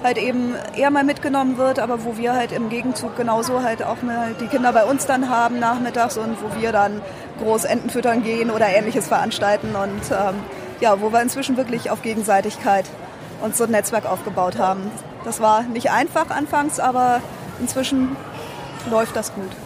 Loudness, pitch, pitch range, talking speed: -20 LUFS, 230 Hz, 215-250 Hz, 175 wpm